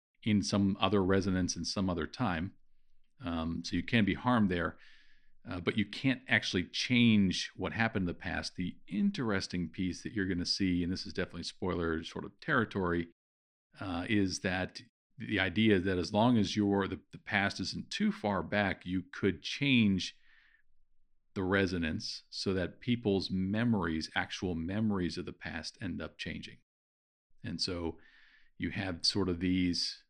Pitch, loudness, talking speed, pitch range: 95 Hz, -33 LUFS, 165 wpm, 85-105 Hz